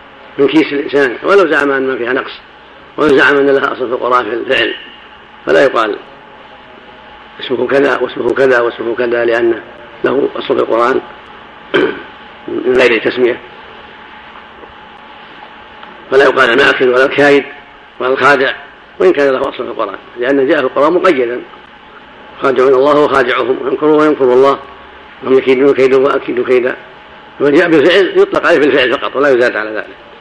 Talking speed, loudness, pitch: 145 wpm, -11 LUFS, 140 Hz